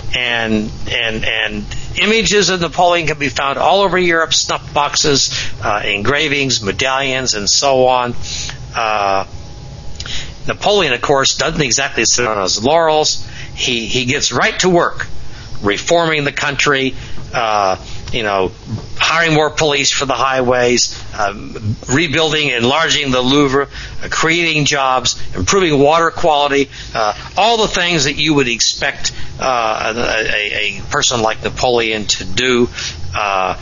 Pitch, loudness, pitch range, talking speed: 130 Hz, -14 LUFS, 115-150 Hz, 135 wpm